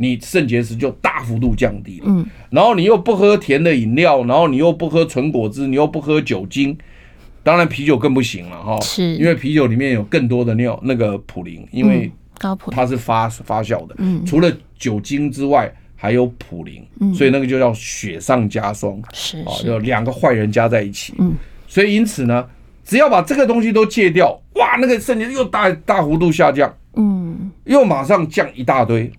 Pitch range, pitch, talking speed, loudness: 115-185 Hz, 140 Hz, 275 characters per minute, -16 LUFS